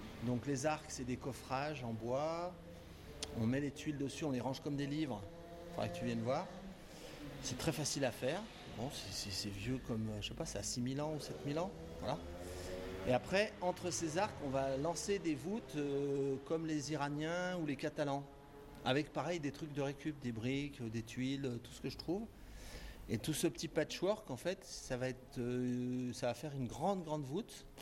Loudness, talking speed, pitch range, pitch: -41 LUFS, 210 wpm, 125-155 Hz, 140 Hz